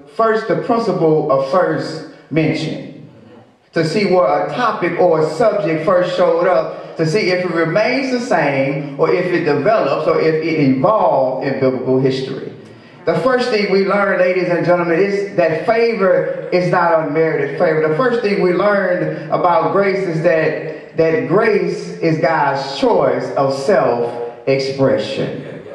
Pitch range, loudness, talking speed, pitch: 145-200 Hz, -15 LUFS, 155 wpm, 175 Hz